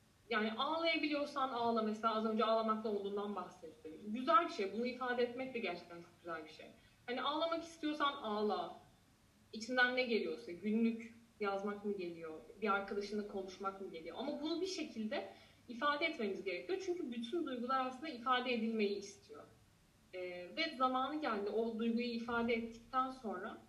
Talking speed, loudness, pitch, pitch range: 150 wpm, -39 LUFS, 230 Hz, 200-260 Hz